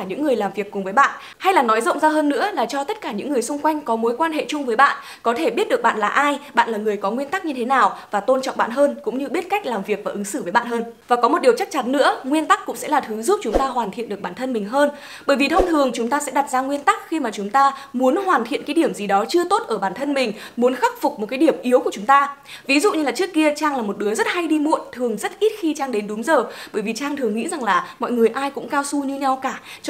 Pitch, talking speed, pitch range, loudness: 275 Hz, 325 wpm, 230-310 Hz, -20 LUFS